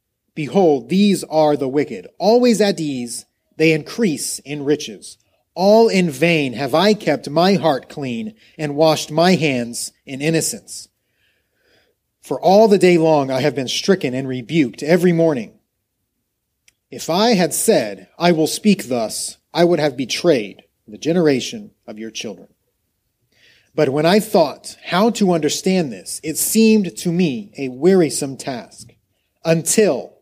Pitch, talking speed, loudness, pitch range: 160 Hz, 145 wpm, -17 LUFS, 135-185 Hz